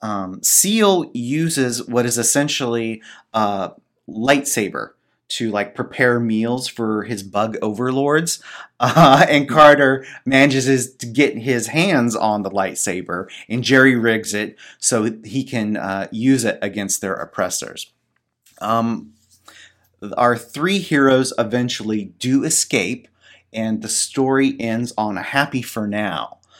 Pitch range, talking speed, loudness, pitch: 110-135 Hz, 130 wpm, -18 LUFS, 120 Hz